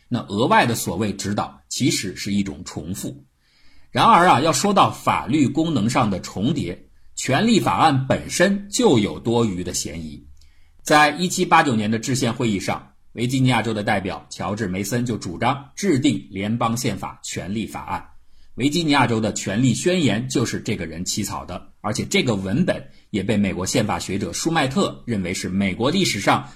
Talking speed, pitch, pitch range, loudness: 275 characters per minute, 110 Hz, 95-130 Hz, -21 LUFS